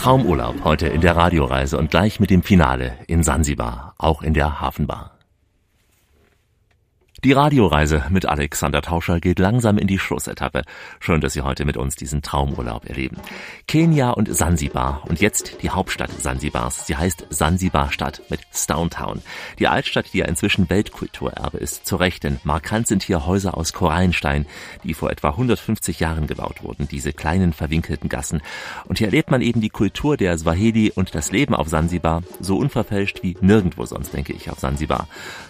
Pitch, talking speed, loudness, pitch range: 85 Hz, 165 wpm, -20 LUFS, 75-100 Hz